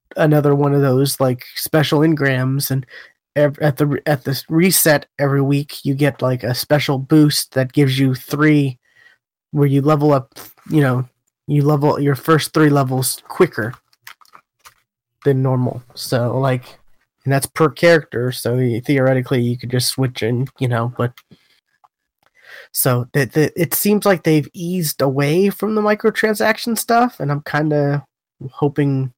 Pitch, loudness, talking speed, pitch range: 140 Hz, -17 LUFS, 150 wpm, 130-150 Hz